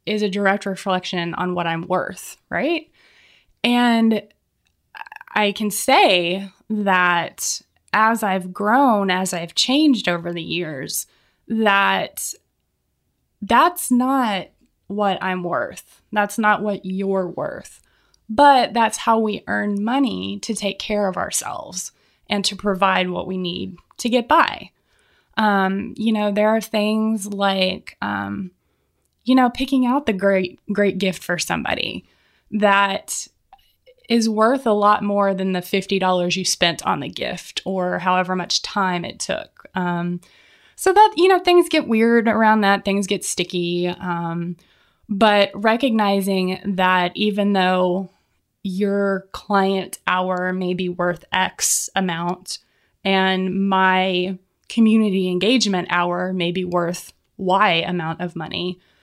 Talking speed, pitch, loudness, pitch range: 135 wpm, 195 Hz, -19 LUFS, 180-220 Hz